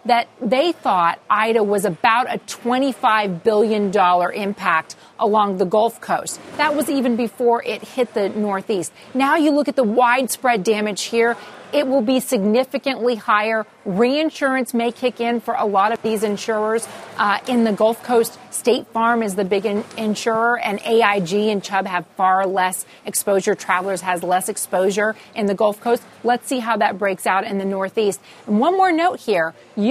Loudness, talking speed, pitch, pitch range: -19 LUFS, 175 wpm, 220 Hz, 200-245 Hz